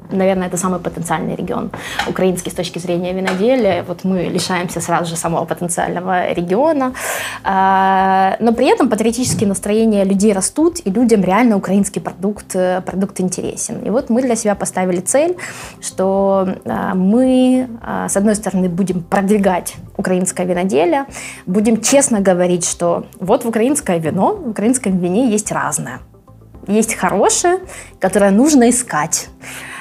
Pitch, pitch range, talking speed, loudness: 195 Hz, 185-230 Hz, 135 wpm, -16 LUFS